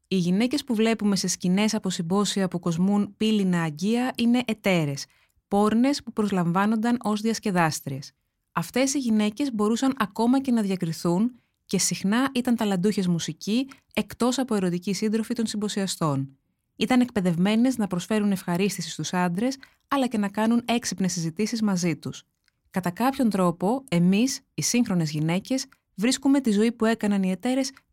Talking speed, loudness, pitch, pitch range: 145 wpm, -25 LUFS, 210 Hz, 180-235 Hz